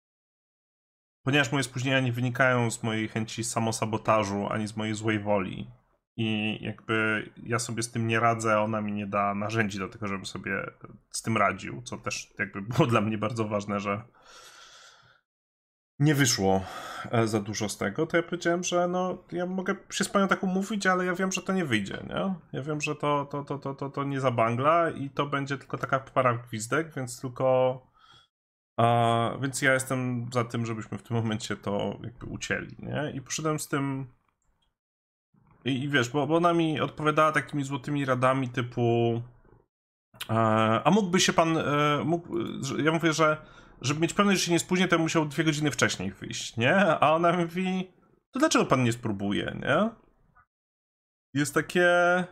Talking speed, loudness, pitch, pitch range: 175 wpm, -27 LUFS, 135 Hz, 110-160 Hz